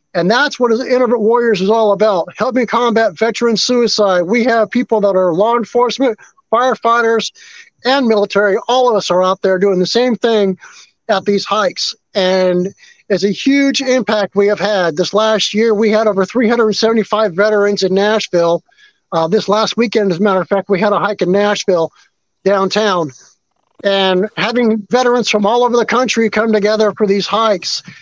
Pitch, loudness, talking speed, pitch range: 215 Hz, -13 LUFS, 175 wpm, 195-235 Hz